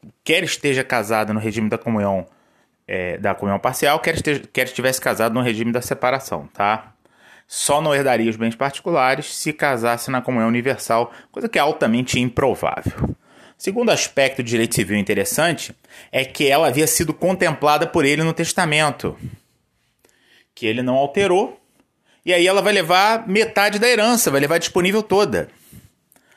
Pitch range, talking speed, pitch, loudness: 115-170 Hz, 155 wpm, 135 Hz, -19 LUFS